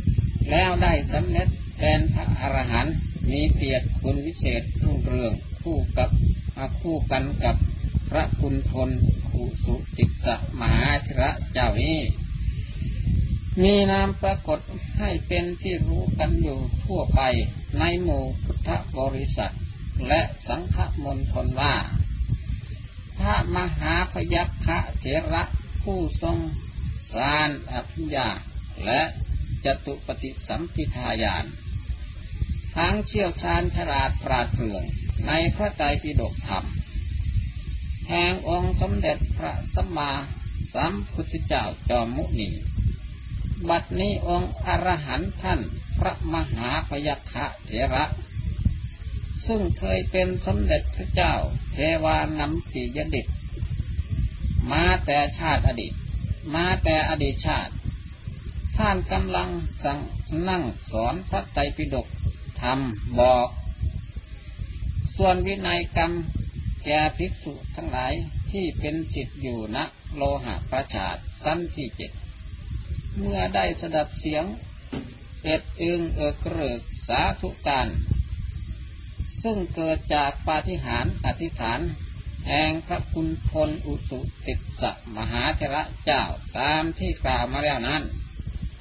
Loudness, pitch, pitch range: -25 LUFS, 95 Hz, 85-115 Hz